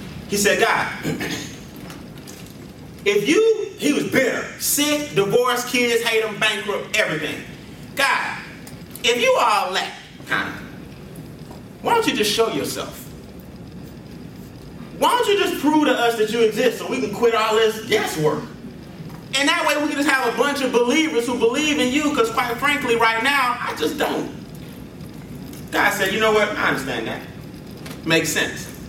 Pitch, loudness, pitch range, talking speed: 245 Hz, -19 LUFS, 220-295 Hz, 160 wpm